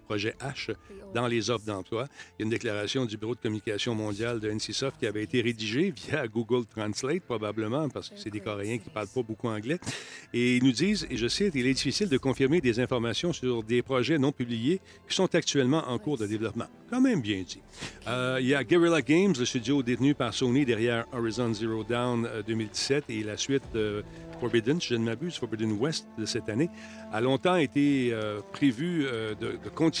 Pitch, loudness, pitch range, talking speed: 120 Hz, -29 LUFS, 110-140 Hz, 210 wpm